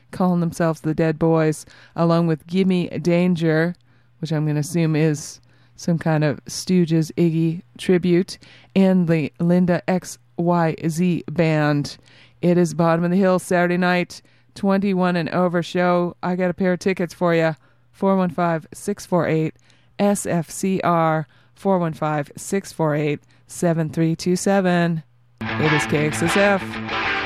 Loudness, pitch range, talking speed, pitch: -20 LUFS, 150-180 Hz, 120 wpm, 165 Hz